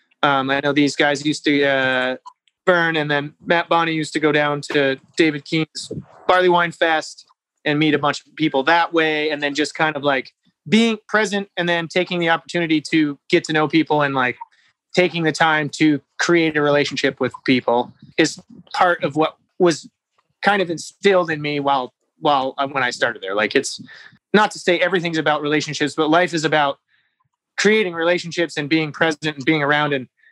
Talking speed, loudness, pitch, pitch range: 190 wpm, -19 LUFS, 155 Hz, 145-170 Hz